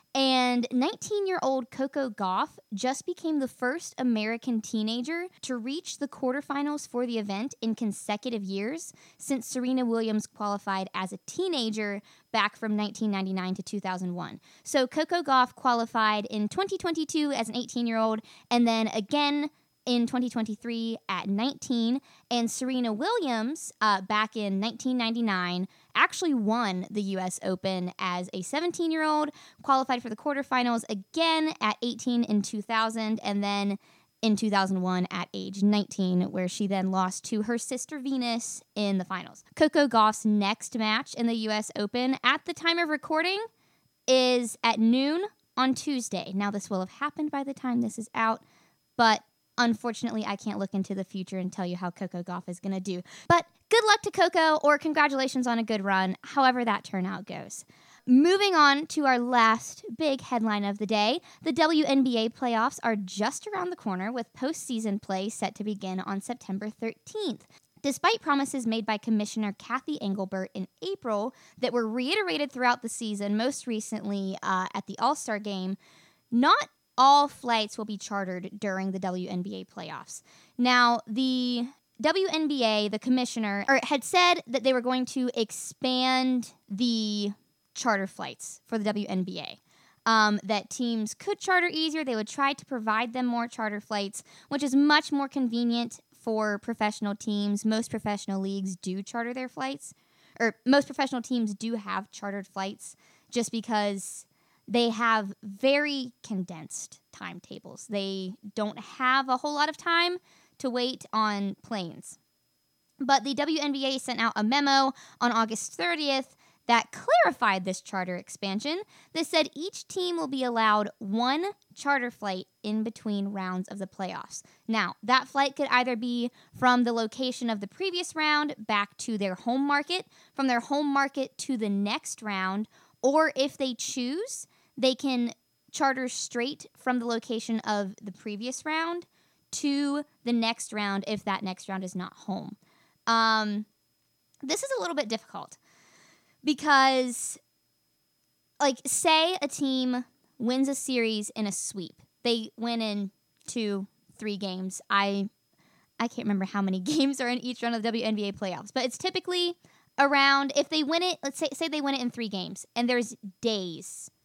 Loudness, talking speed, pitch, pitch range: -28 LUFS, 160 wpm, 235 Hz, 205-275 Hz